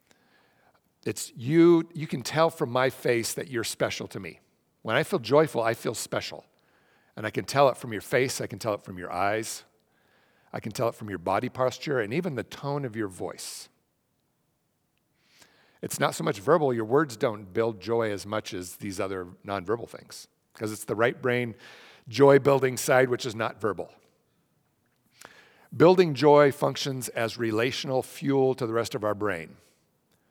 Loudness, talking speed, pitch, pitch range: -26 LUFS, 180 wpm, 120 Hz, 110-140 Hz